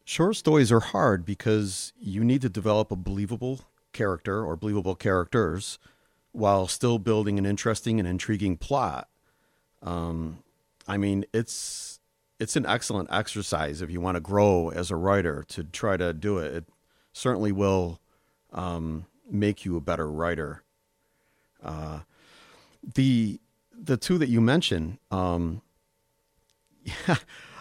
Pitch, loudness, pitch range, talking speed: 100 Hz, -27 LUFS, 90-110 Hz, 135 wpm